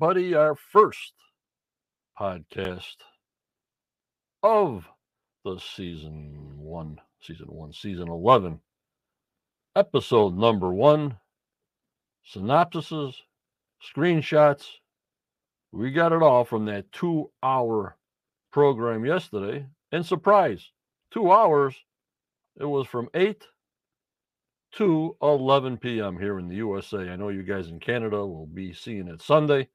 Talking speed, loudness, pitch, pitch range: 105 wpm, -24 LUFS, 125 Hz, 95-150 Hz